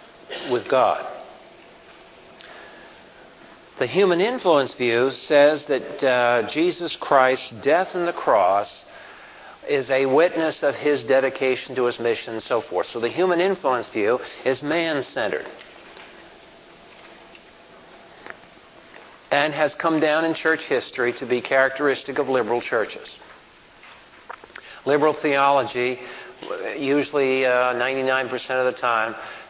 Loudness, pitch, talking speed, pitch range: -21 LUFS, 135 Hz, 110 wpm, 125-150 Hz